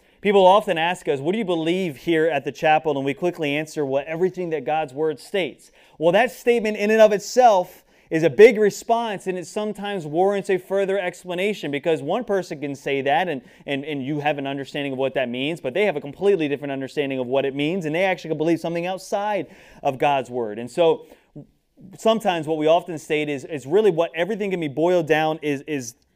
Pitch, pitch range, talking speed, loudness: 165 Hz, 145-195 Hz, 220 wpm, -22 LUFS